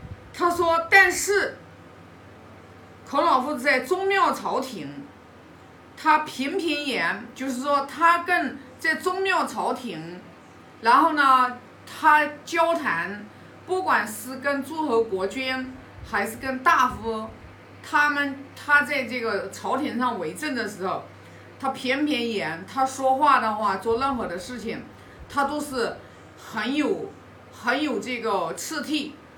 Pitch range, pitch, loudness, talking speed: 240-310 Hz, 275 Hz, -23 LUFS, 175 characters per minute